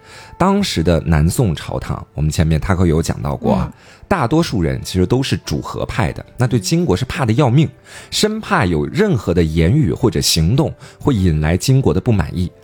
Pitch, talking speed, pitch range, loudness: 100 Hz, 285 characters per minute, 85-140 Hz, -16 LUFS